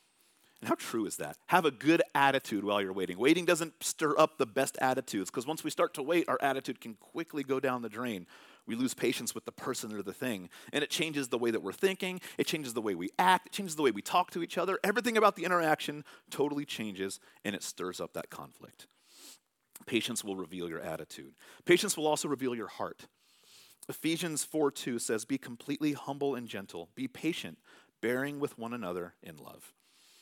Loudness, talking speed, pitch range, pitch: -32 LUFS, 205 wpm, 125-170 Hz, 145 Hz